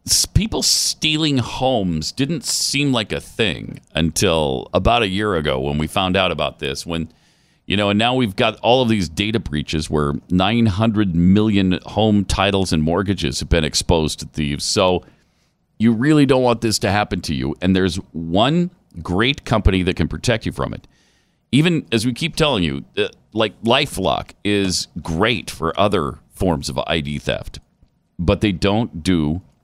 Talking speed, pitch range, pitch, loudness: 170 wpm, 80-115 Hz, 95 Hz, -18 LUFS